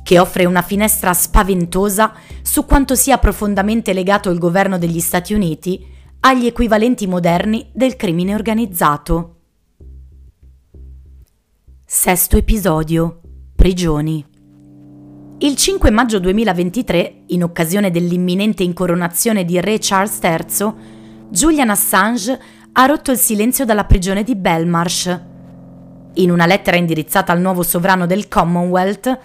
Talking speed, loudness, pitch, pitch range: 115 wpm, -15 LUFS, 180 Hz, 165-210 Hz